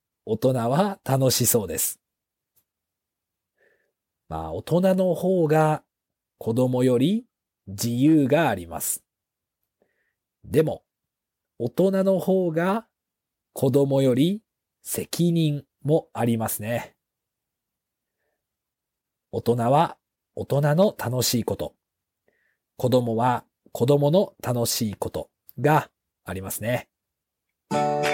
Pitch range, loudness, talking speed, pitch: 115-165 Hz, -23 LUFS, 160 characters per minute, 130 Hz